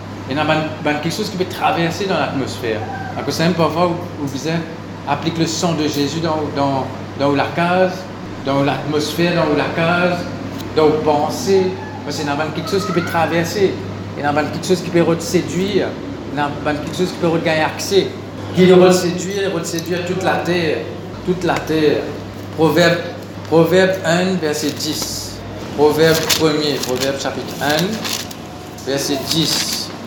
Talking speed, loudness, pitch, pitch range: 150 wpm, -17 LUFS, 150 Hz, 130-170 Hz